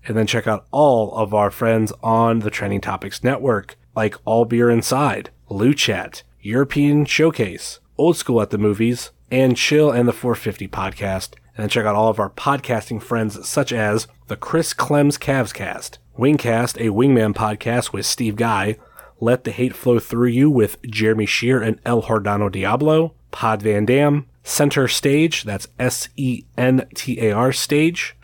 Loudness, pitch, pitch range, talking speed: -19 LUFS, 115 Hz, 110-130 Hz, 175 wpm